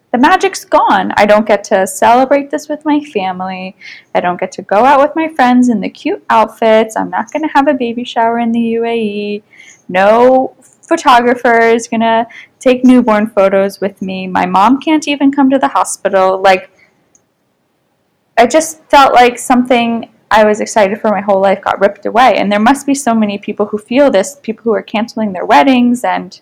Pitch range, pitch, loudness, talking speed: 205-270 Hz, 230 Hz, -11 LUFS, 200 wpm